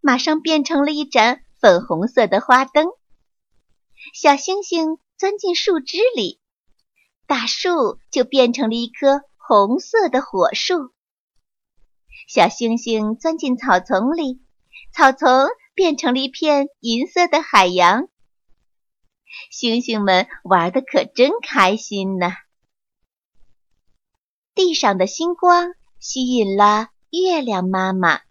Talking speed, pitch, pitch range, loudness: 160 characters per minute, 265 Hz, 220-325 Hz, -17 LUFS